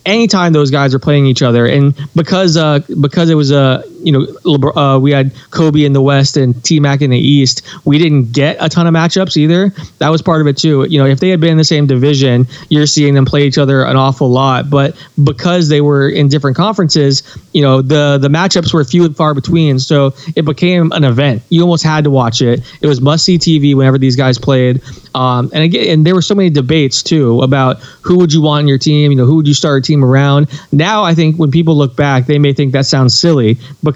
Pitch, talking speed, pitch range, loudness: 145 Hz, 245 wpm, 135-160 Hz, -10 LUFS